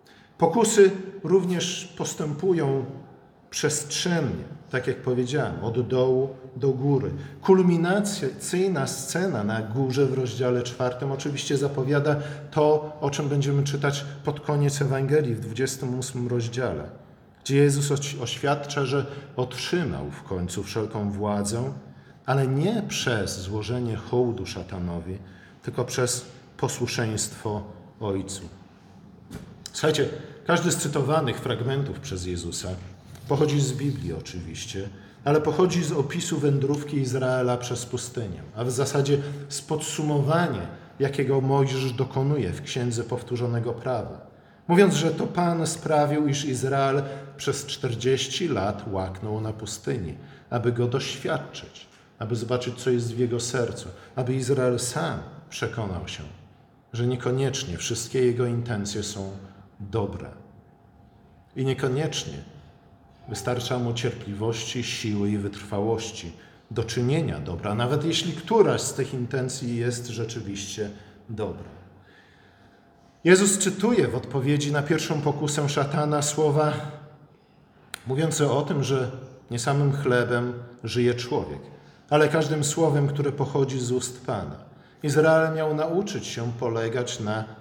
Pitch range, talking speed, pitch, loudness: 115-150 Hz, 115 wpm, 130 Hz, -26 LUFS